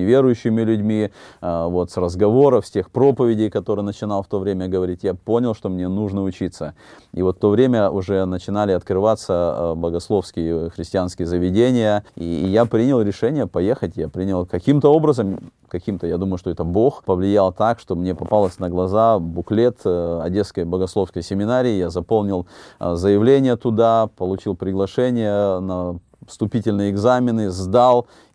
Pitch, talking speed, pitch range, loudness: 100 Hz, 140 wpm, 90-115 Hz, -19 LUFS